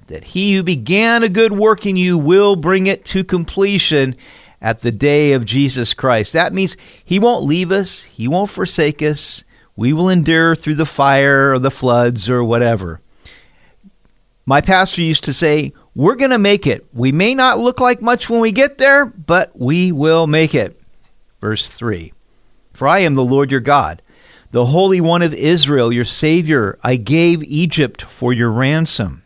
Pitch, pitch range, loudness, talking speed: 155 Hz, 130-190 Hz, -14 LUFS, 180 wpm